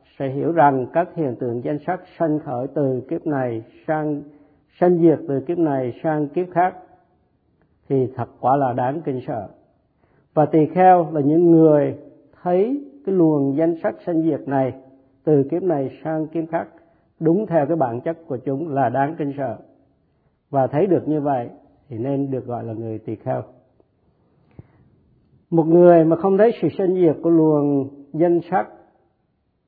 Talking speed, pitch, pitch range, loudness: 170 wpm, 150 Hz, 135-170 Hz, -20 LUFS